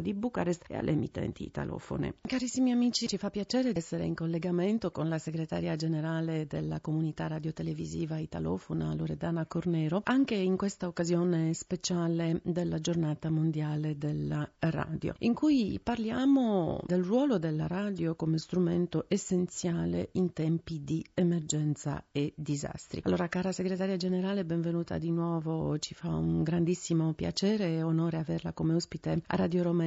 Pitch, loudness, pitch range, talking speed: 170 Hz, -32 LUFS, 160-185 Hz, 140 wpm